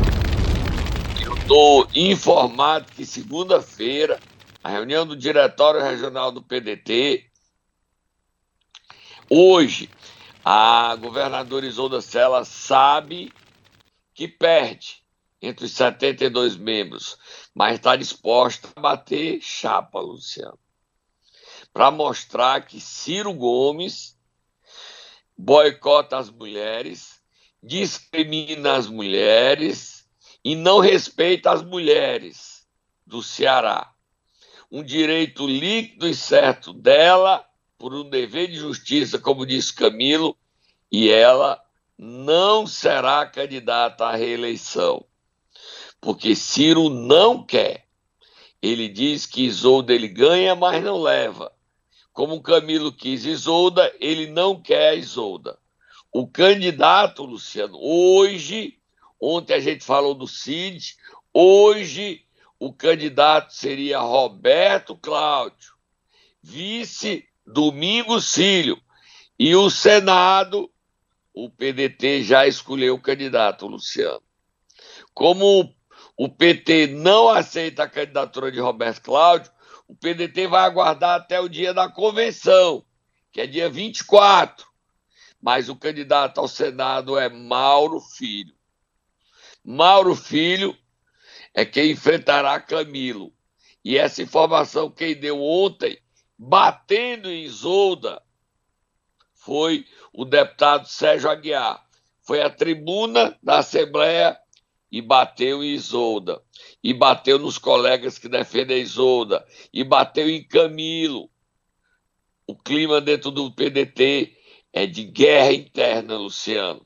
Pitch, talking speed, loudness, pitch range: 160 Hz, 105 wpm, -19 LUFS, 135-210 Hz